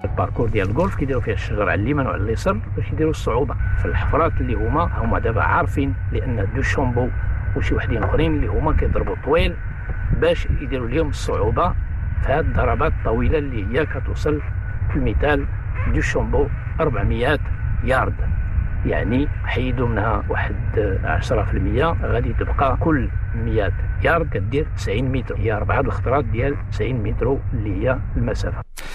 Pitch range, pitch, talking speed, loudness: 100-115 Hz, 105 Hz, 145 wpm, -21 LUFS